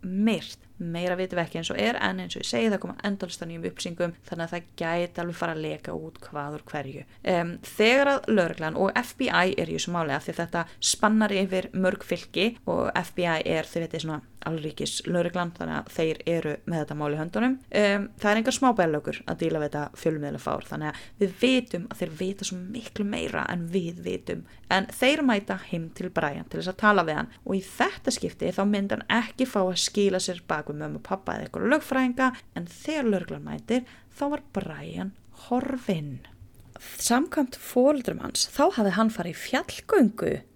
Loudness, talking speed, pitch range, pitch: -27 LUFS, 195 wpm, 160-215 Hz, 180 Hz